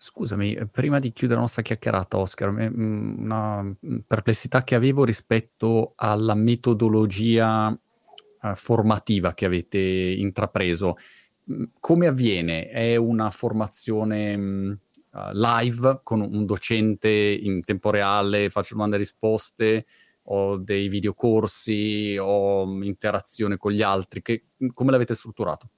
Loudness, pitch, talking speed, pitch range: -23 LUFS, 110 Hz, 110 wpm, 100-115 Hz